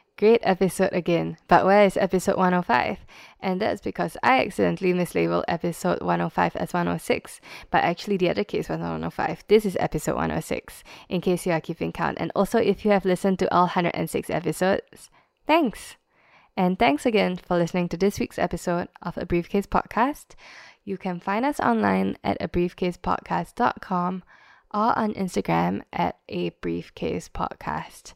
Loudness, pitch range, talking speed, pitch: -24 LUFS, 170-200 Hz, 160 wpm, 180 Hz